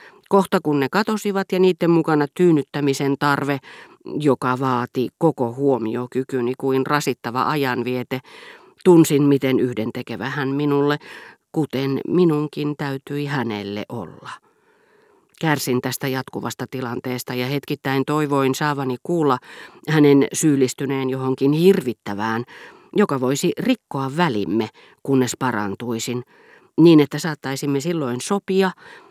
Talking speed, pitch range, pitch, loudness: 105 wpm, 130-160 Hz, 140 Hz, -20 LUFS